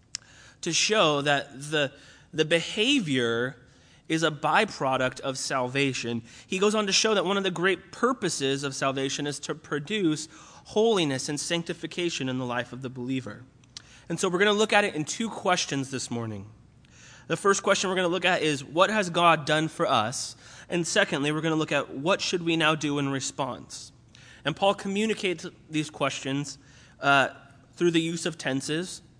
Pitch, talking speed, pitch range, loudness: 150 Hz, 175 wpm, 130-180 Hz, -26 LUFS